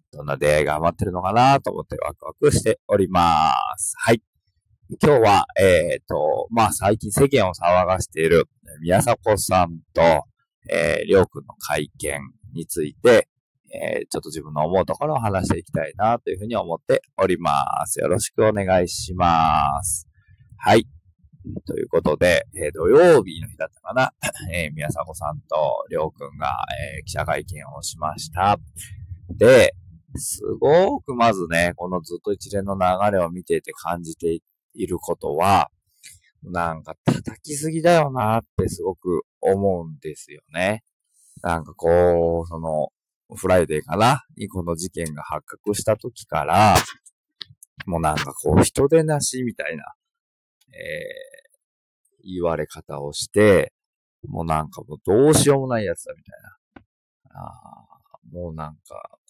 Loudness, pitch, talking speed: -21 LUFS, 100 Hz, 295 characters per minute